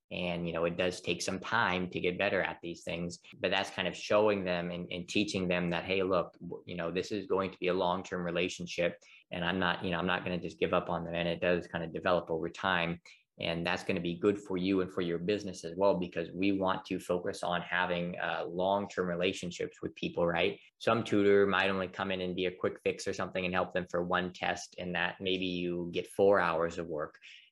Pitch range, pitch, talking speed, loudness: 85-95 Hz, 90 Hz, 255 wpm, -33 LUFS